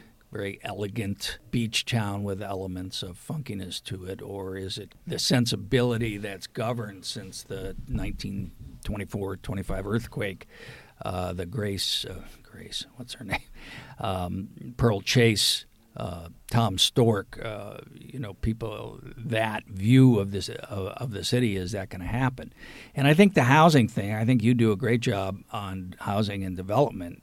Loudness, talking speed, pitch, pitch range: -27 LUFS, 150 wpm, 105 Hz, 95-125 Hz